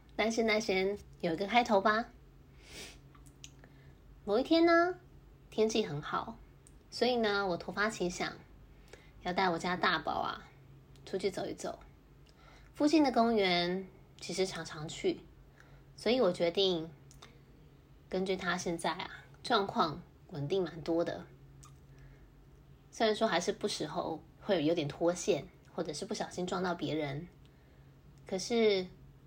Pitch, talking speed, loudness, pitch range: 180 Hz, 190 characters per minute, -33 LUFS, 150-205 Hz